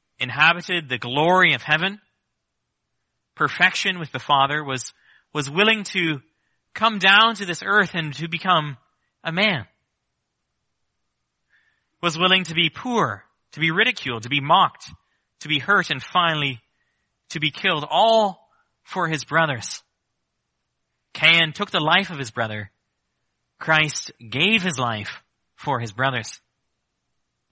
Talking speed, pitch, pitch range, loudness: 130 wpm, 155 Hz, 135-185 Hz, -20 LUFS